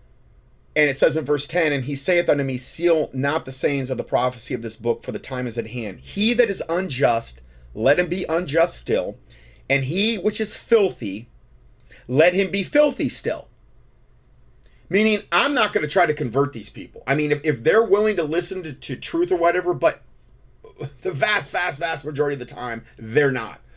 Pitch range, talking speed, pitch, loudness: 130-180 Hz, 200 wpm, 150 Hz, -21 LUFS